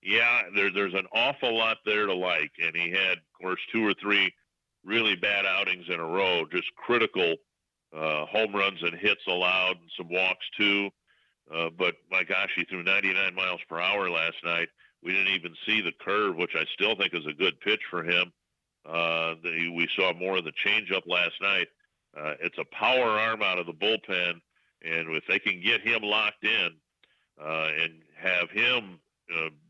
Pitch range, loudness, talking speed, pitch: 85-105 Hz, -26 LUFS, 190 wpm, 95 Hz